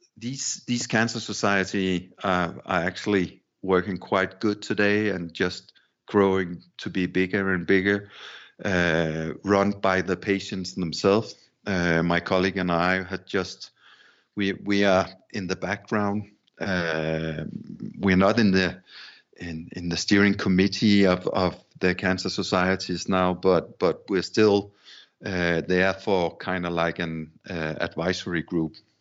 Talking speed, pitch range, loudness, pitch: 140 wpm, 90-100 Hz, -25 LUFS, 95 Hz